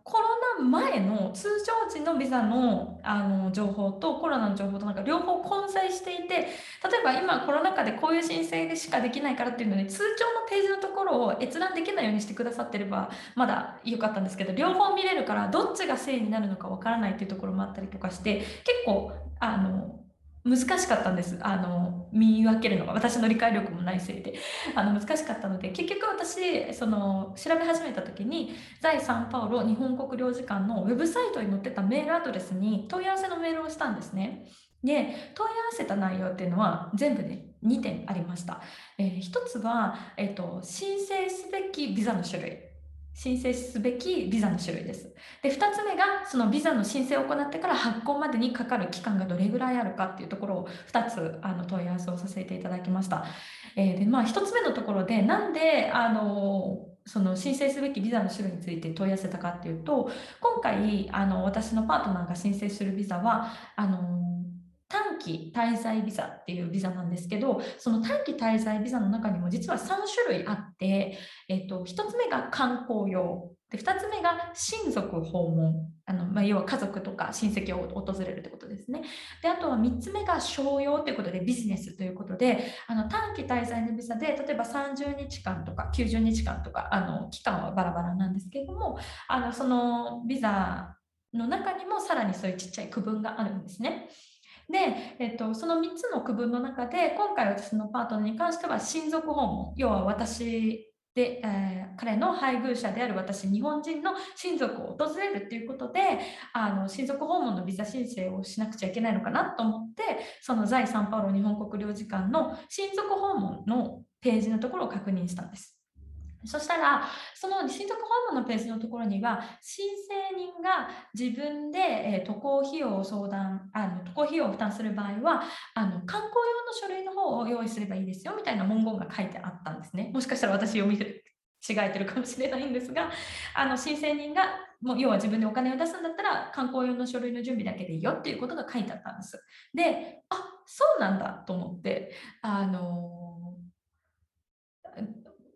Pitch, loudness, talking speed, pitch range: 225 Hz, -29 LUFS, 370 characters per minute, 195-290 Hz